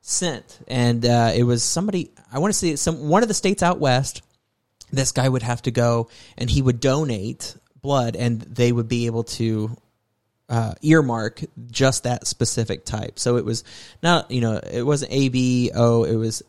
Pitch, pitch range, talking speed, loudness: 120 Hz, 115-135 Hz, 185 wpm, -21 LUFS